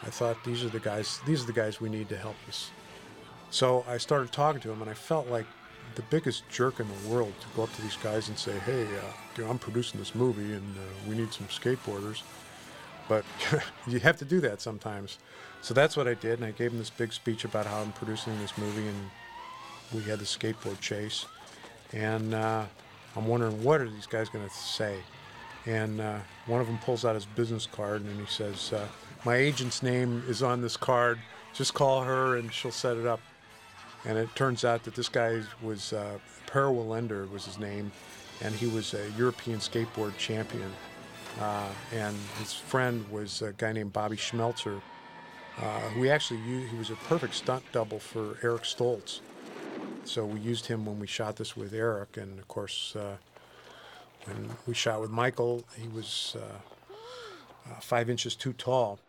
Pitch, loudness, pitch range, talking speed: 115 Hz, -32 LUFS, 105-120 Hz, 200 wpm